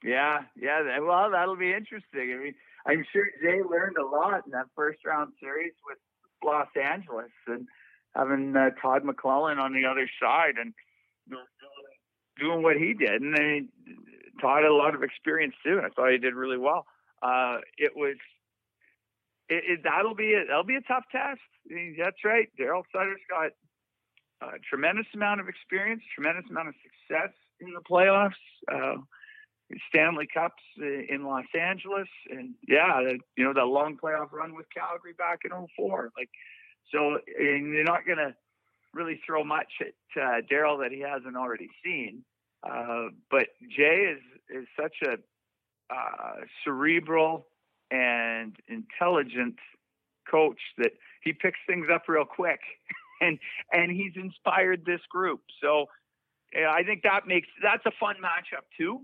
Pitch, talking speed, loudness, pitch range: 160 Hz, 160 wpm, -27 LUFS, 140-190 Hz